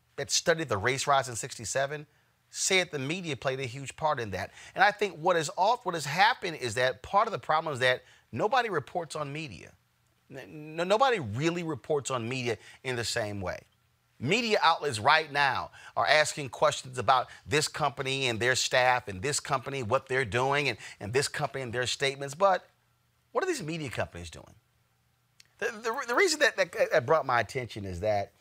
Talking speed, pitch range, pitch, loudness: 195 wpm, 125-160 Hz, 140 Hz, -28 LUFS